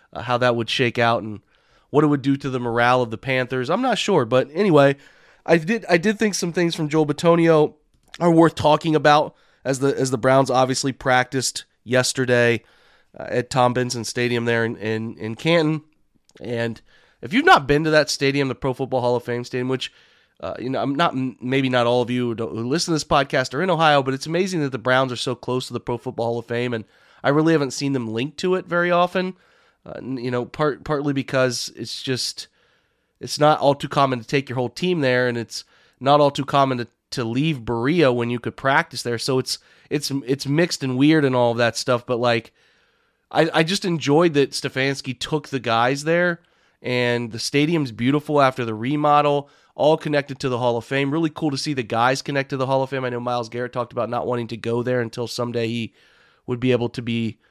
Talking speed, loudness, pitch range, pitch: 225 wpm, -21 LUFS, 120-150 Hz, 130 Hz